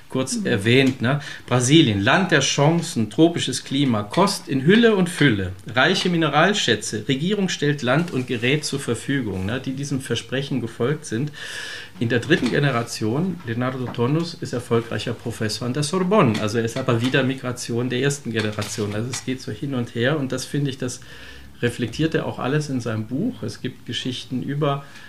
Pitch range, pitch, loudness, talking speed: 120-150 Hz, 130 Hz, -21 LUFS, 175 wpm